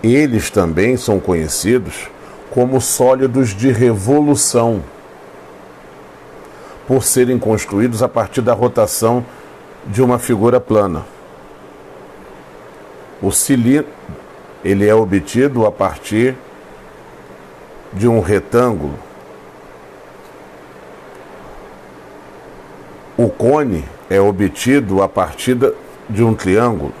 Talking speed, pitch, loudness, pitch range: 85 wpm, 115 Hz, -14 LUFS, 100-125 Hz